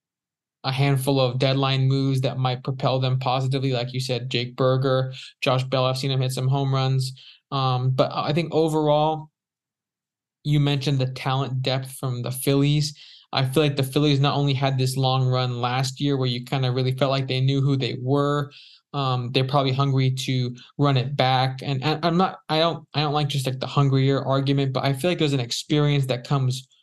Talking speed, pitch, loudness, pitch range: 210 wpm, 135 Hz, -23 LUFS, 130-145 Hz